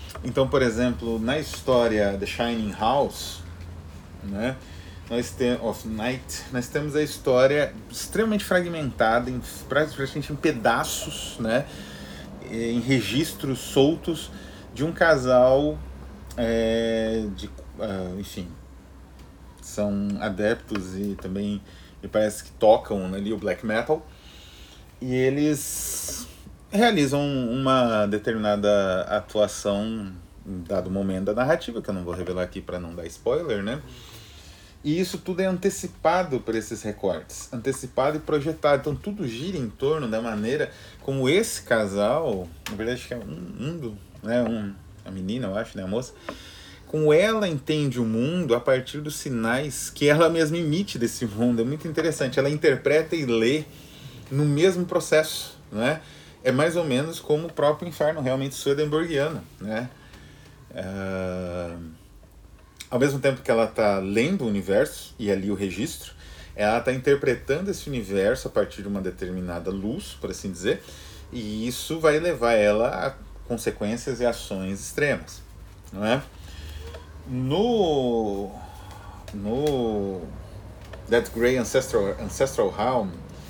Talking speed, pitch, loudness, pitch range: 135 wpm, 115 Hz, -25 LUFS, 95-140 Hz